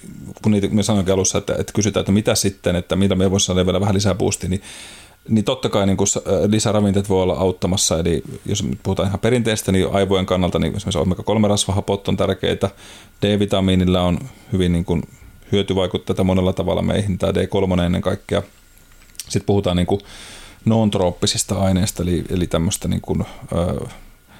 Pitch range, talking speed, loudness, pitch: 95-100 Hz, 165 wpm, -19 LUFS, 95 Hz